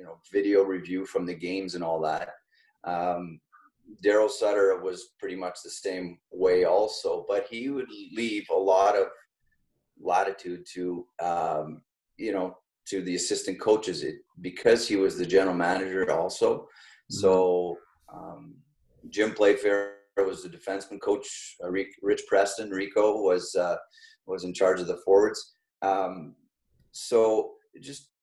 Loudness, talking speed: -27 LUFS, 140 wpm